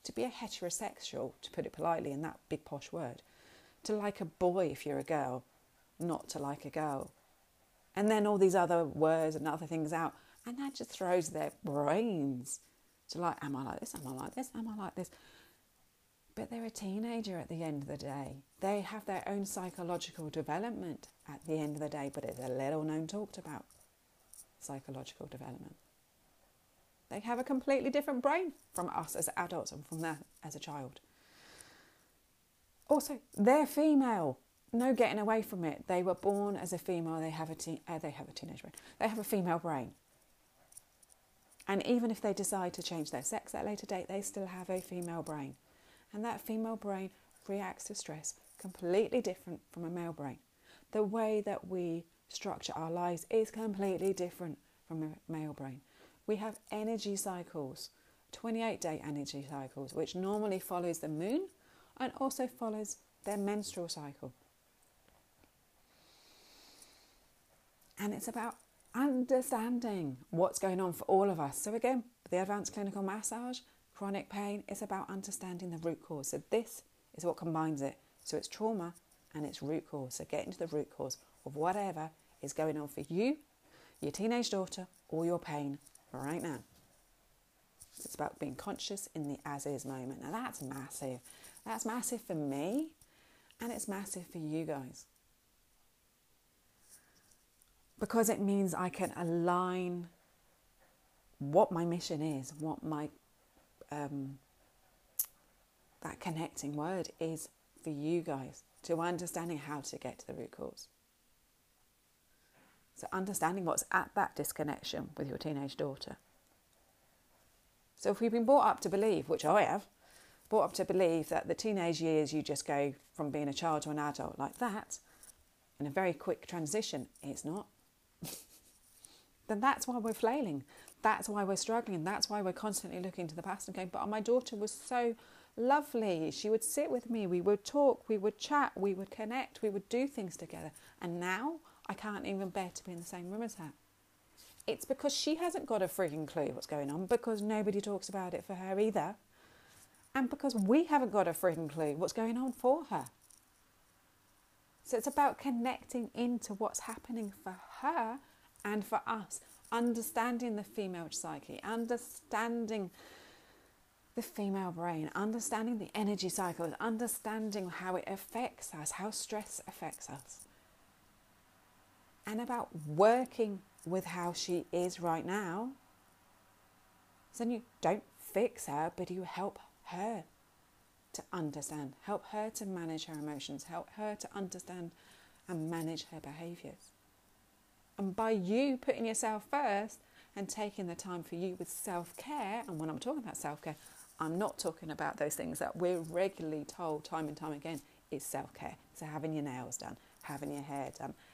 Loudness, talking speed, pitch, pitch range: -37 LUFS, 165 wpm, 185 Hz, 155-220 Hz